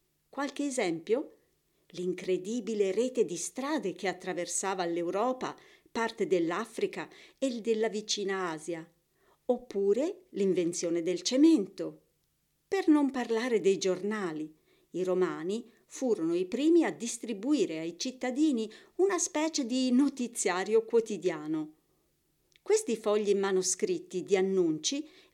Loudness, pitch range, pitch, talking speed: -30 LUFS, 185-285 Hz, 225 Hz, 100 wpm